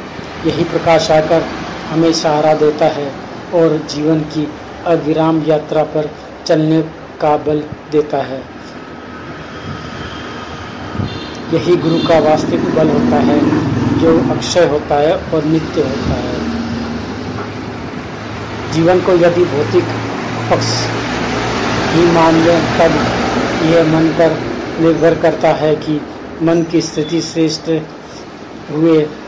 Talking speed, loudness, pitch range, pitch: 110 wpm, -14 LUFS, 150-165 Hz, 160 Hz